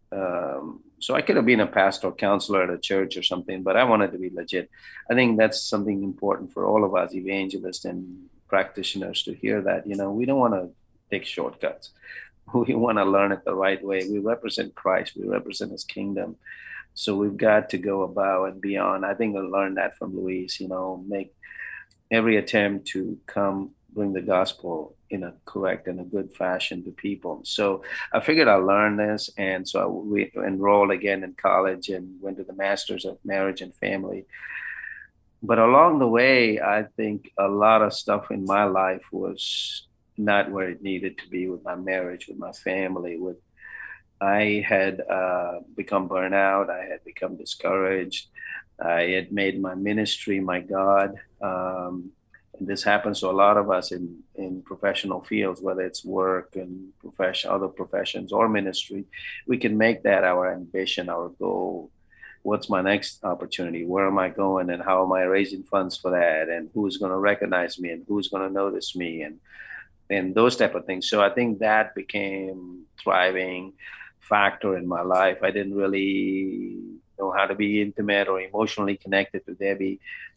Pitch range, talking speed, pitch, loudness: 95-100 Hz, 185 wpm, 95 Hz, -24 LUFS